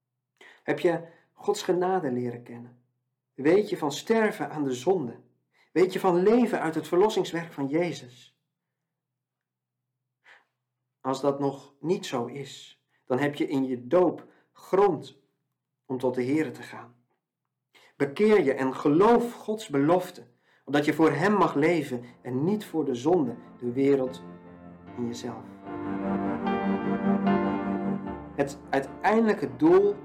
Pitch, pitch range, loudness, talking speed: 140 Hz, 125-180 Hz, -26 LUFS, 130 wpm